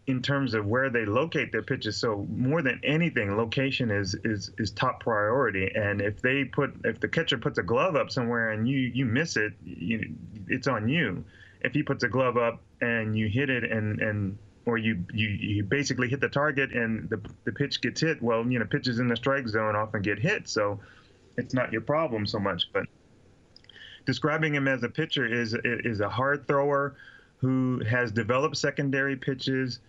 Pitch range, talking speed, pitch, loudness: 110-135 Hz, 200 wpm, 120 Hz, -28 LUFS